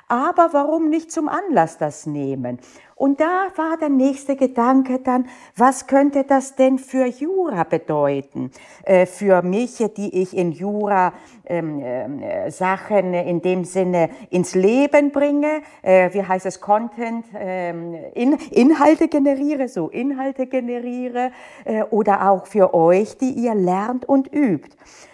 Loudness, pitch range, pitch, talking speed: -19 LUFS, 185-280 Hz, 245 Hz, 140 wpm